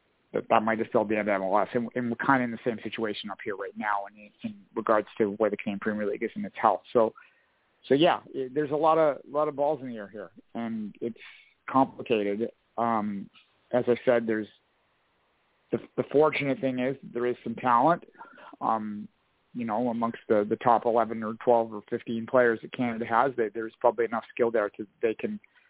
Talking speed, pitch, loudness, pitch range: 210 wpm, 115 Hz, -28 LUFS, 110-130 Hz